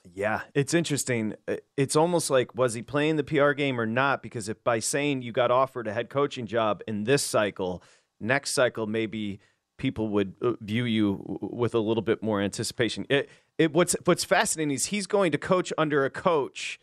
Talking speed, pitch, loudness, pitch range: 195 wpm, 125 Hz, -26 LUFS, 110-145 Hz